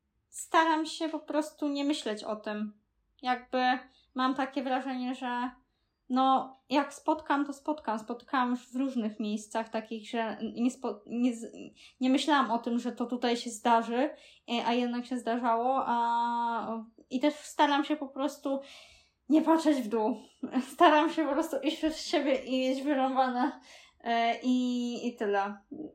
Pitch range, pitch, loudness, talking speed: 235-285 Hz, 255 Hz, -30 LUFS, 150 wpm